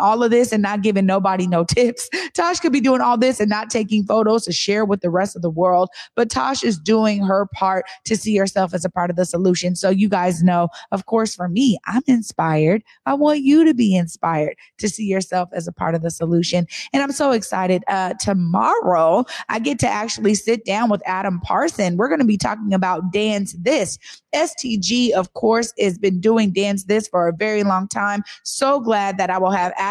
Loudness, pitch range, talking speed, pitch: -19 LUFS, 185-225 Hz, 220 wpm, 200 Hz